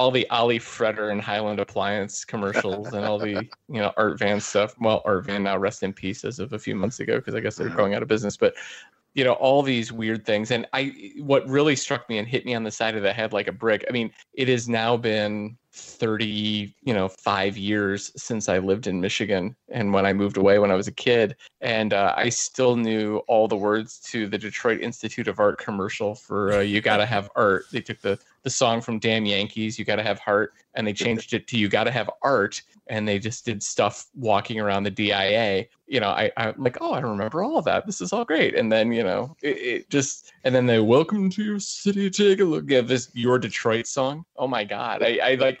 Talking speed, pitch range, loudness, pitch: 240 wpm, 105-125 Hz, -24 LUFS, 110 Hz